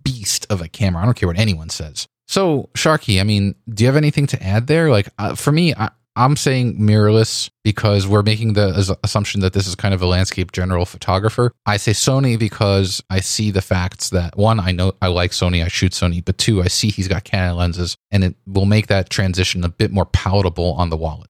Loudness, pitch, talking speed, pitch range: -17 LUFS, 100 Hz, 230 wpm, 90-110 Hz